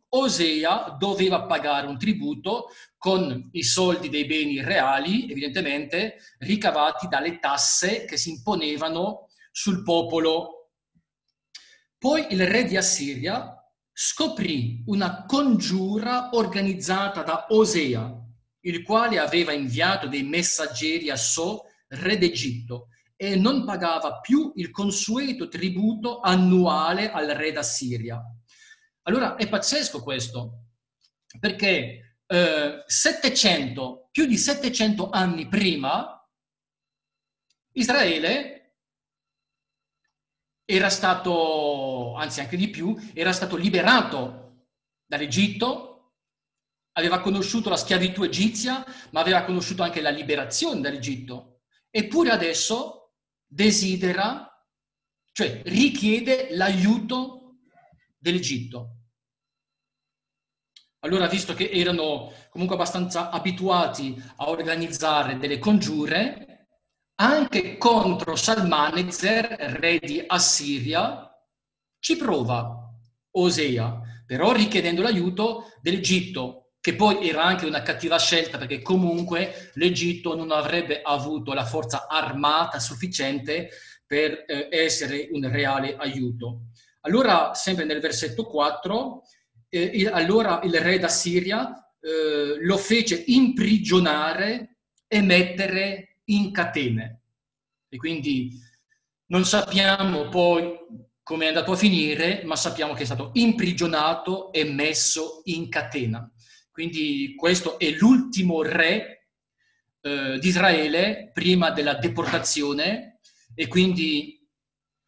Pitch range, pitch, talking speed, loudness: 145-200 Hz, 170 Hz, 100 wpm, -23 LUFS